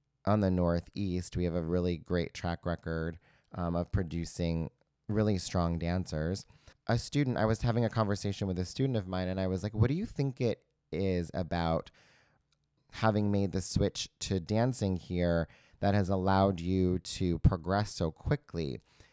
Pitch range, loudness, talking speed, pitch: 85-105 Hz, -32 LUFS, 170 wpm, 95 Hz